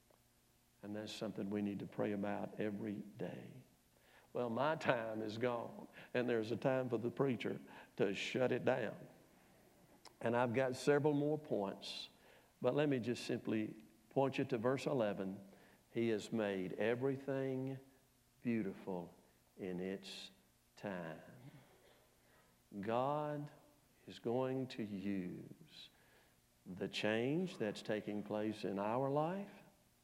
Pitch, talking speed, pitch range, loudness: 115 Hz, 125 wpm, 100-130 Hz, -41 LUFS